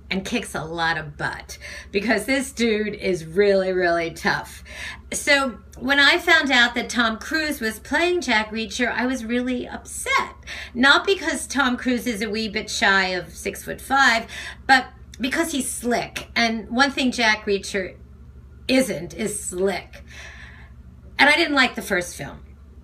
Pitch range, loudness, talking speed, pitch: 180-260 Hz, -21 LUFS, 160 wpm, 225 Hz